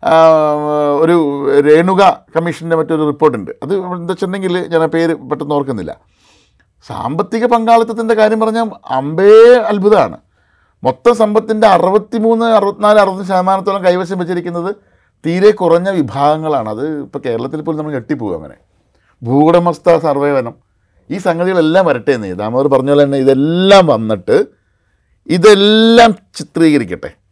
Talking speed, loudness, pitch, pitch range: 110 wpm, -12 LUFS, 170 Hz, 145-200 Hz